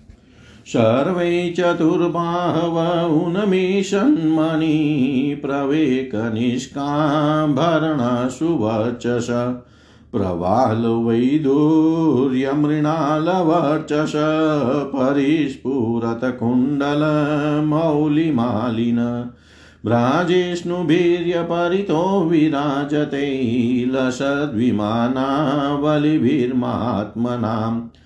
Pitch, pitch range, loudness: 145 Hz, 125-160 Hz, -19 LUFS